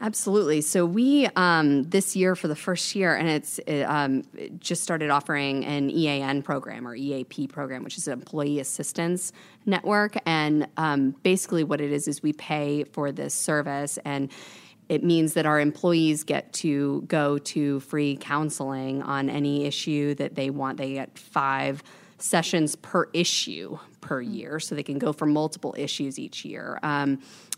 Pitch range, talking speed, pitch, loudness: 140-170 Hz, 170 wpm, 150 Hz, -26 LUFS